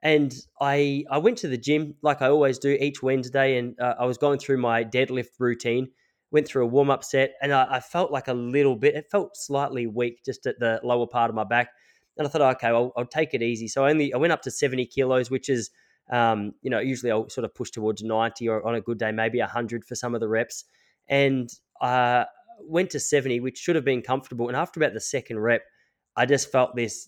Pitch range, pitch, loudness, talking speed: 120-140 Hz, 130 Hz, -25 LUFS, 245 wpm